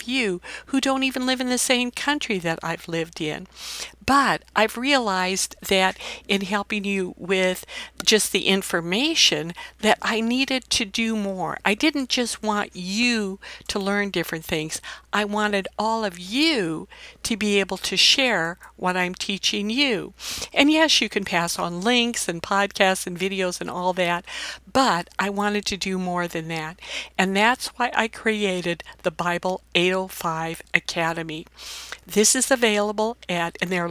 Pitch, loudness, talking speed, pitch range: 200 Hz, -22 LUFS, 160 wpm, 180-235 Hz